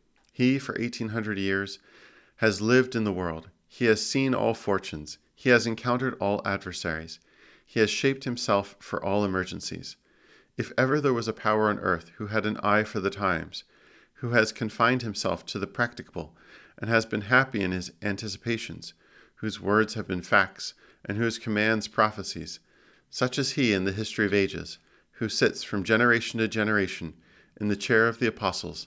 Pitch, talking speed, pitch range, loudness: 105 Hz, 175 wpm, 95-115 Hz, -27 LUFS